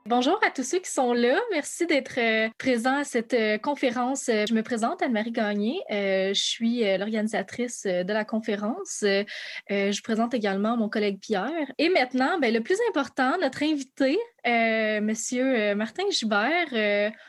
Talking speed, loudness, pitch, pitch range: 170 wpm, -25 LUFS, 235 Hz, 215-275 Hz